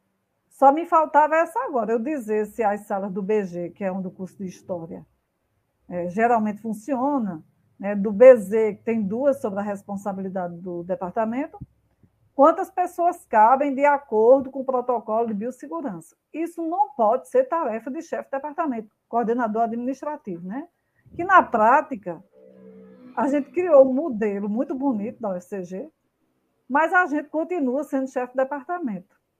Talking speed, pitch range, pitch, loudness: 155 wpm, 205-290 Hz, 240 Hz, -22 LUFS